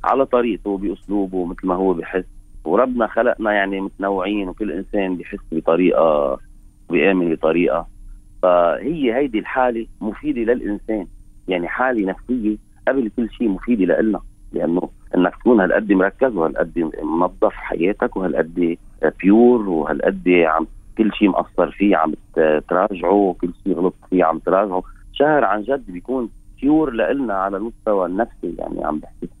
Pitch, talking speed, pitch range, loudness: 100 Hz, 135 wpm, 90-110 Hz, -19 LUFS